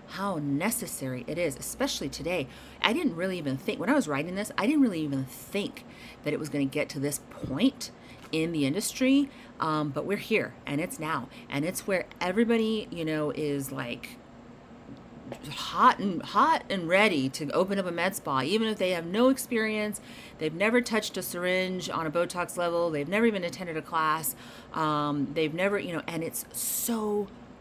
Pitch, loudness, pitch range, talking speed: 175 Hz, -29 LUFS, 150-215 Hz, 190 wpm